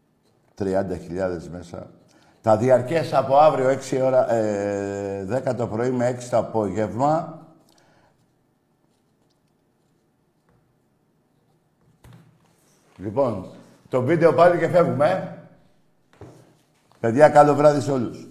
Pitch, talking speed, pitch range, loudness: 130 Hz, 90 wpm, 110-150 Hz, -20 LUFS